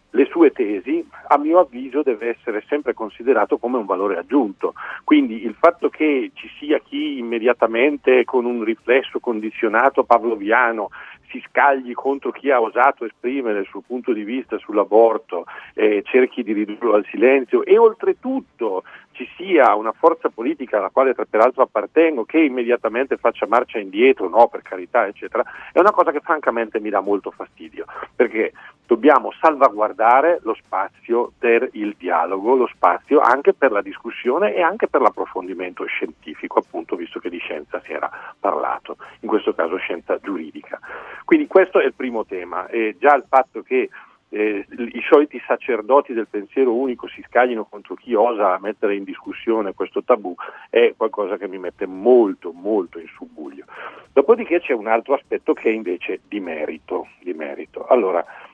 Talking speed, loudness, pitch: 165 wpm, -19 LUFS, 165 Hz